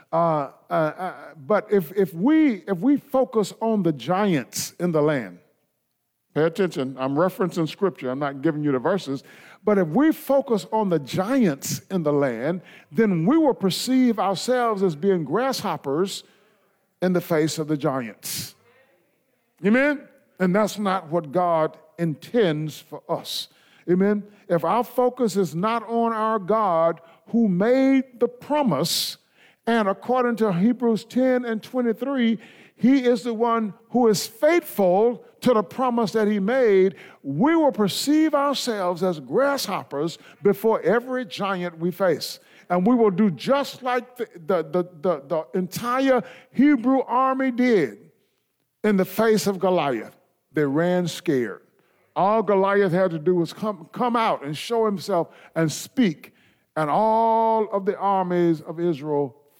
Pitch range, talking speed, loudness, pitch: 170-235 Hz, 150 wpm, -22 LUFS, 200 Hz